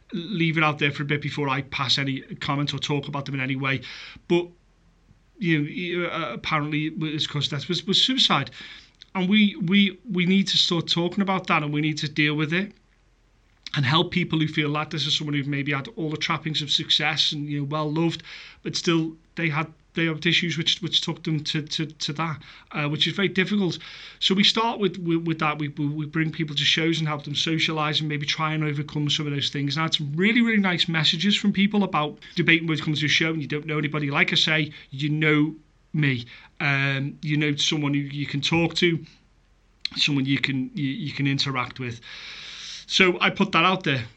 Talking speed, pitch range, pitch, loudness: 220 wpm, 145-170 Hz, 155 Hz, -23 LUFS